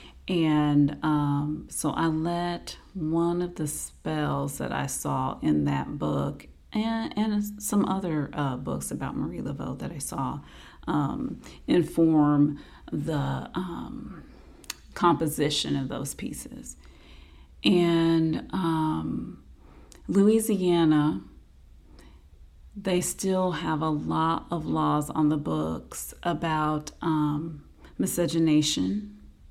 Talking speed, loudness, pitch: 105 wpm, -27 LUFS, 155 Hz